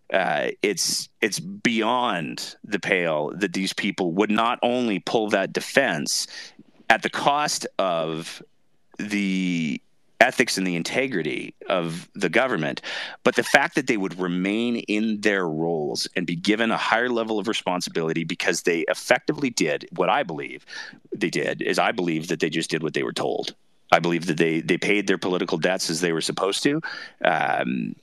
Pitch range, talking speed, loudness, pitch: 85-110 Hz, 170 wpm, -23 LUFS, 95 Hz